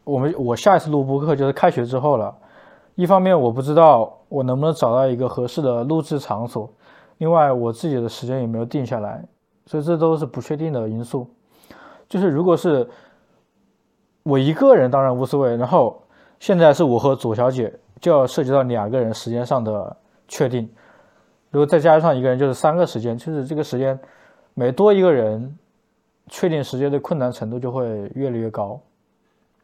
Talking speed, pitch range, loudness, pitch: 285 characters per minute, 120-155 Hz, -19 LUFS, 135 Hz